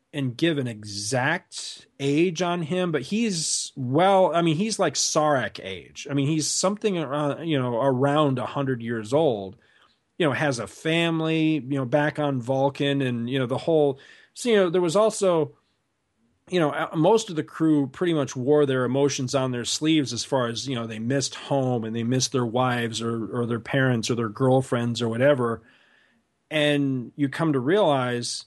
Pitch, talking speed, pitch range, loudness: 140 Hz, 190 wpm, 125-160 Hz, -24 LUFS